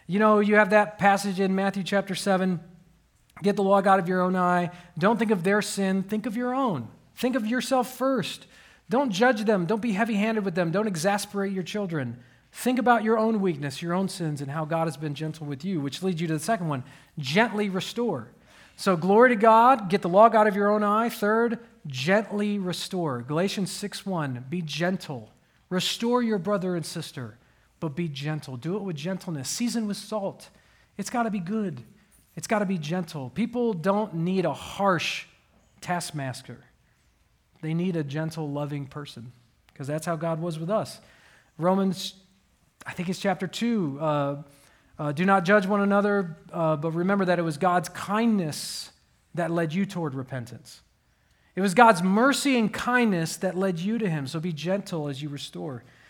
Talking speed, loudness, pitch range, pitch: 185 wpm, -25 LUFS, 160-210 Hz, 185 Hz